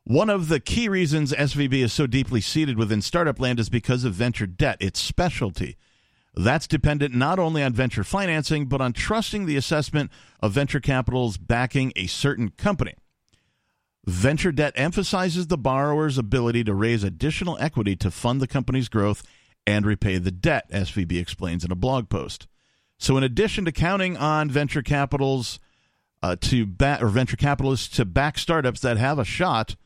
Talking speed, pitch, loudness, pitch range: 170 wpm, 130 Hz, -23 LUFS, 110-150 Hz